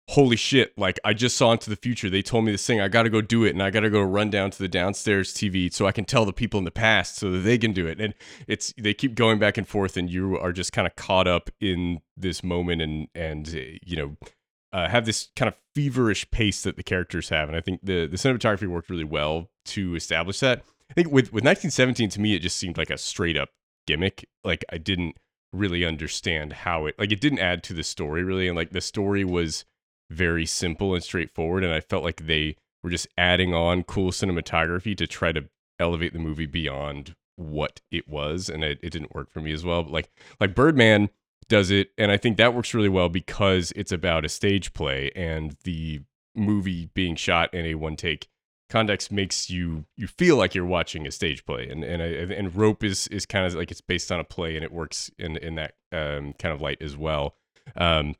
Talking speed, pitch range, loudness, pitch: 235 wpm, 80-105 Hz, -25 LUFS, 90 Hz